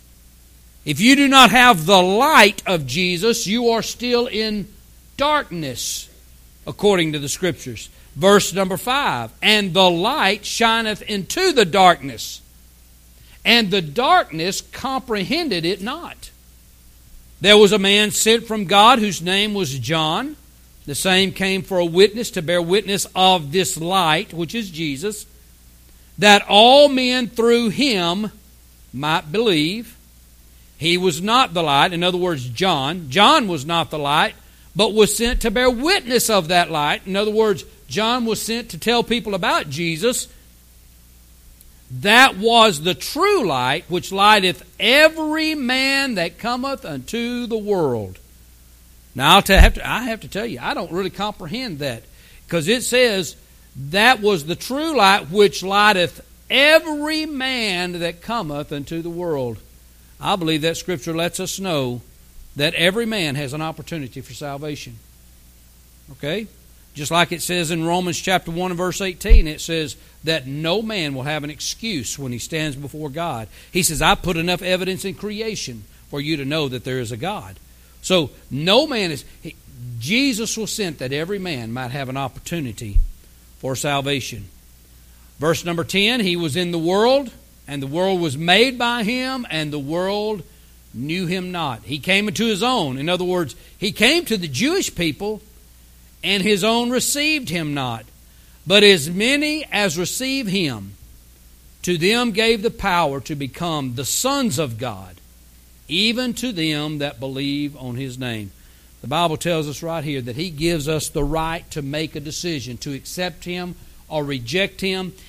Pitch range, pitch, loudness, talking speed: 135-210 Hz, 175 Hz, -18 LUFS, 160 wpm